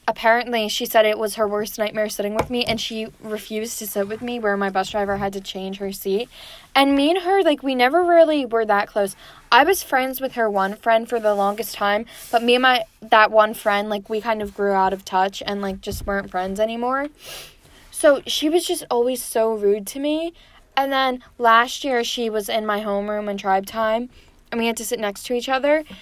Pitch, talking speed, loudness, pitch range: 225 Hz, 230 wpm, -20 LUFS, 205-245 Hz